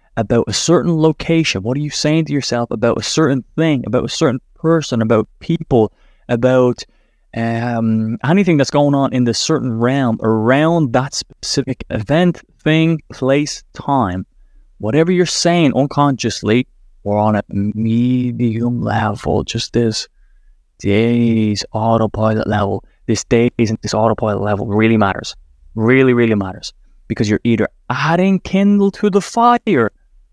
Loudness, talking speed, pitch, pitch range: -16 LUFS, 140 wpm, 120 Hz, 110-150 Hz